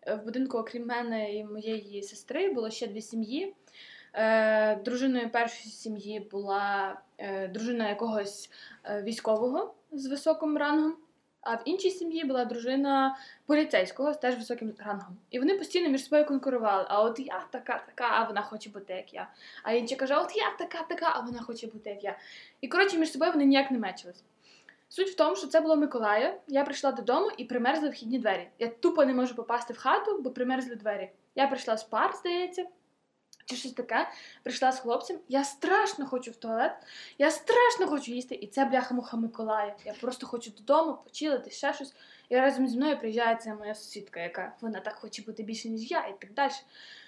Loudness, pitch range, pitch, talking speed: -30 LUFS, 220-290 Hz, 250 Hz, 180 wpm